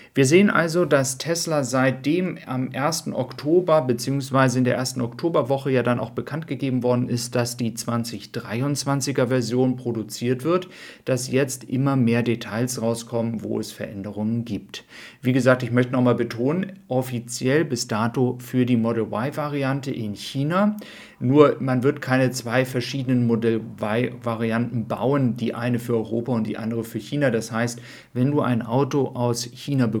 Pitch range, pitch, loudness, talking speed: 115-135 Hz, 125 Hz, -23 LUFS, 160 wpm